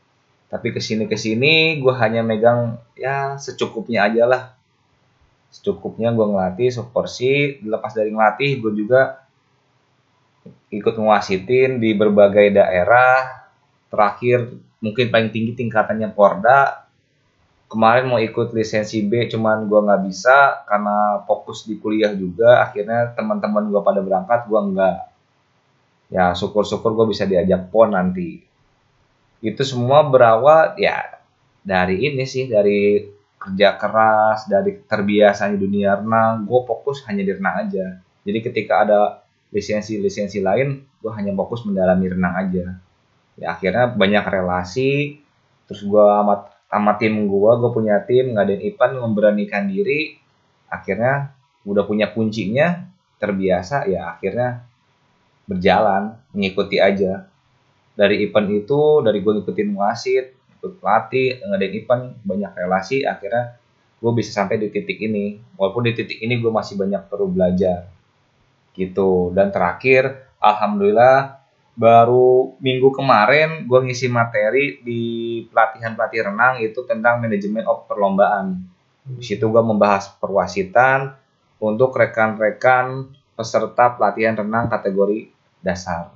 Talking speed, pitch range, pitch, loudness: 125 wpm, 105-130 Hz, 115 Hz, -18 LUFS